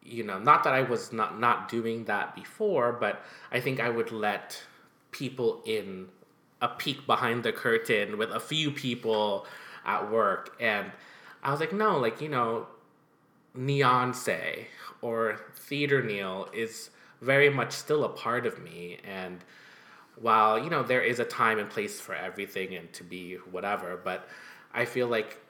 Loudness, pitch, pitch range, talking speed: -29 LUFS, 120 Hz, 105-140 Hz, 165 wpm